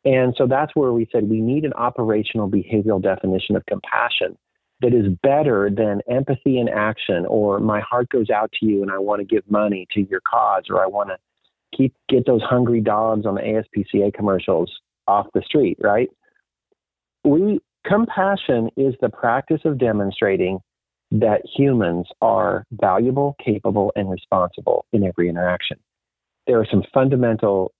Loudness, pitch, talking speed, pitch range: -20 LUFS, 110 Hz, 160 wpm, 100-125 Hz